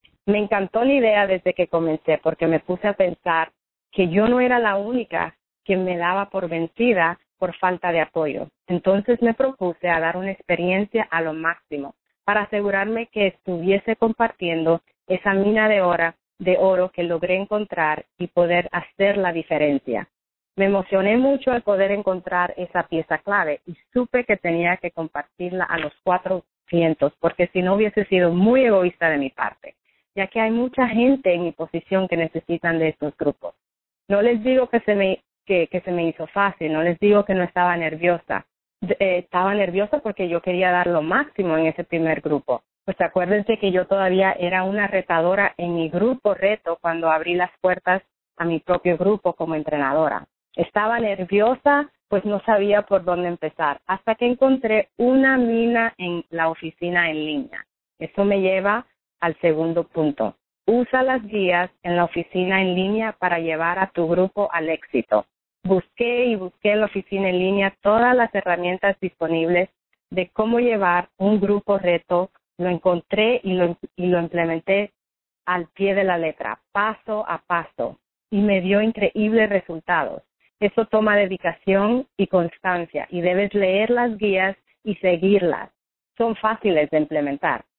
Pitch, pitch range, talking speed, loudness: 185 Hz, 170-205 Hz, 165 wpm, -21 LUFS